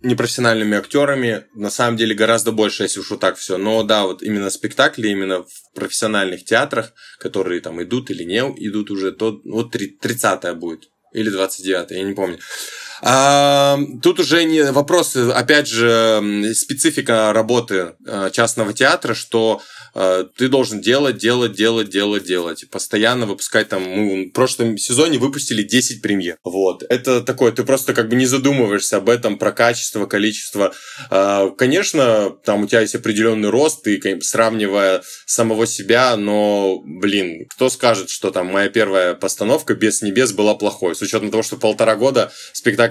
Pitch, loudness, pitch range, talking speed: 110 Hz, -17 LUFS, 100-125 Hz, 160 wpm